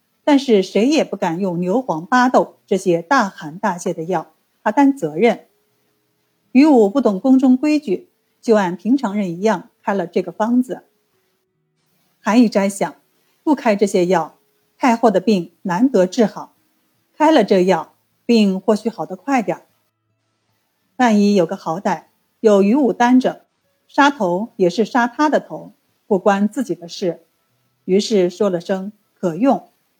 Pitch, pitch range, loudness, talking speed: 210 Hz, 180-240 Hz, -17 LUFS, 210 characters per minute